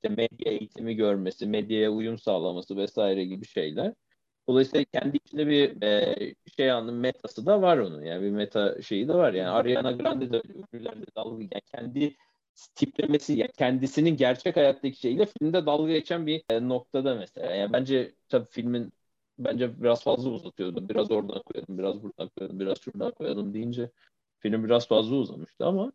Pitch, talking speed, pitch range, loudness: 120 Hz, 155 wpm, 110-145 Hz, -28 LUFS